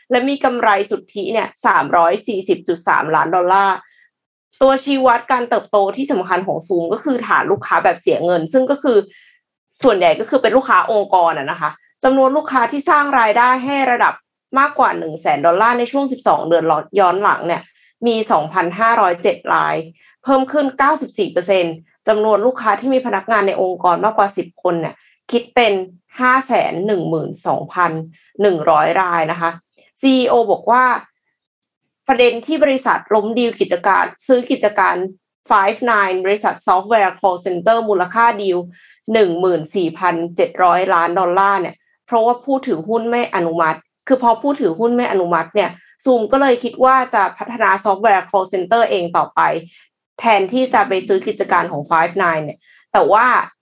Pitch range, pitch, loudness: 180-255 Hz, 215 Hz, -16 LUFS